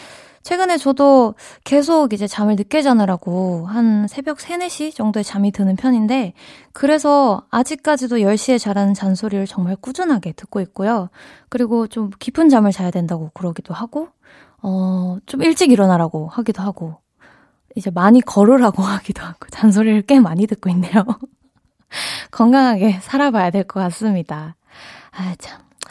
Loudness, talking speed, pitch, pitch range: -17 LUFS, 310 characters per minute, 215 Hz, 190-265 Hz